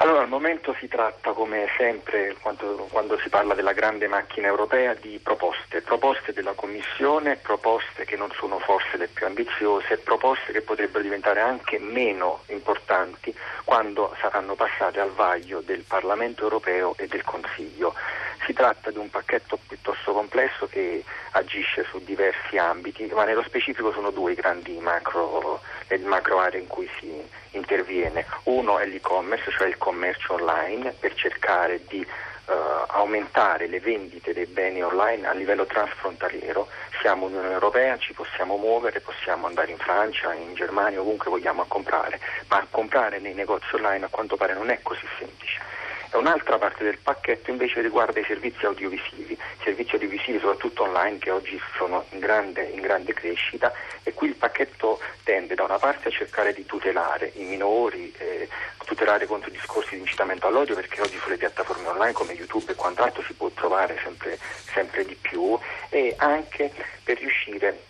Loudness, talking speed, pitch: -25 LUFS, 160 wpm, 135 Hz